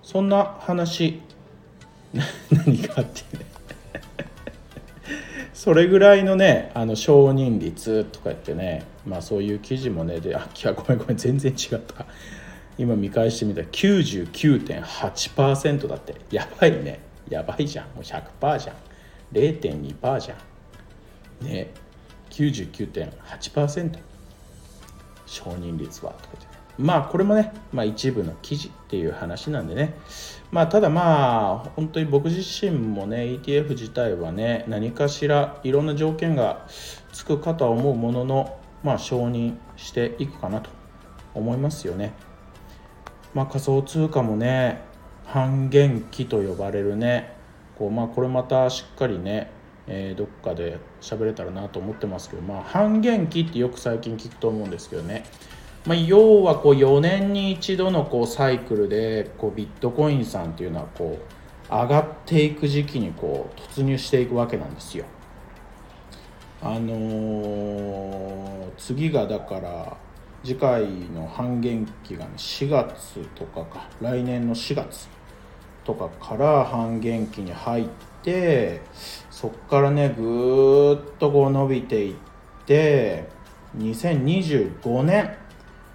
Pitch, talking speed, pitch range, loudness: 125 Hz, 250 characters per minute, 110-150 Hz, -23 LUFS